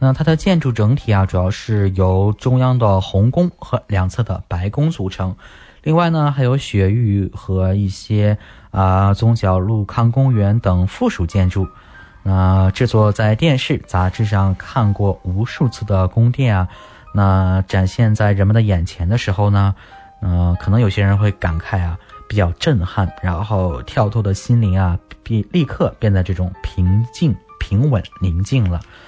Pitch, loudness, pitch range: 100 Hz, -17 LUFS, 95-115 Hz